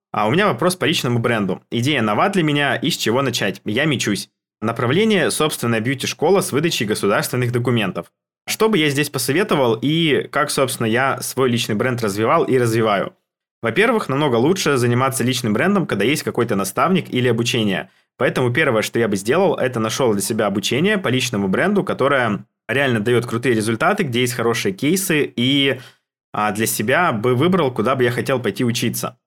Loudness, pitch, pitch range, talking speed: -18 LUFS, 125 Hz, 115-140 Hz, 175 wpm